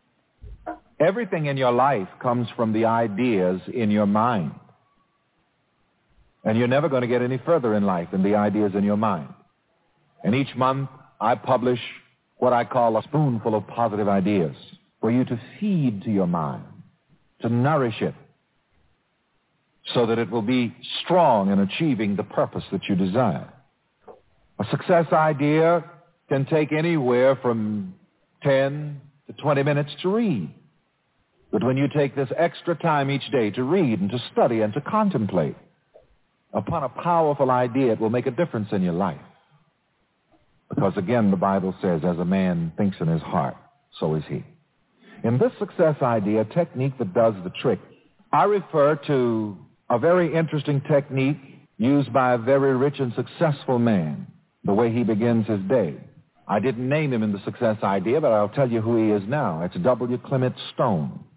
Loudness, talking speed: -23 LUFS, 165 wpm